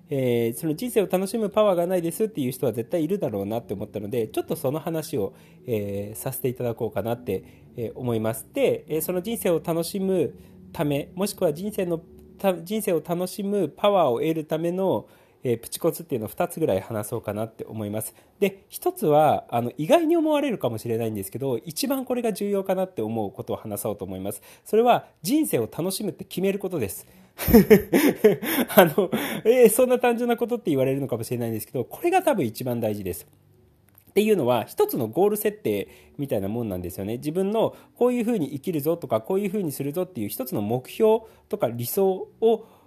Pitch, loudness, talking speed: 160 Hz, -25 LUFS, 420 characters per minute